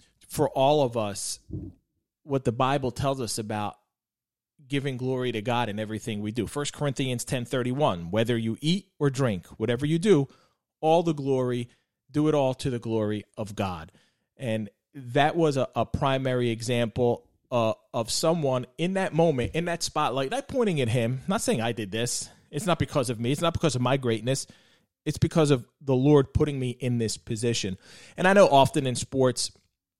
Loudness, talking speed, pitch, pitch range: -26 LUFS, 185 wpm, 130 Hz, 115-145 Hz